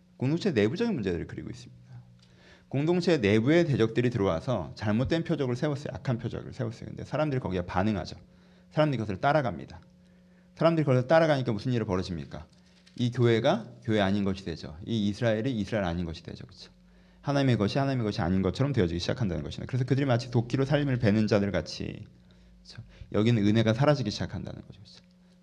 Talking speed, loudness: 465 characters per minute, -28 LUFS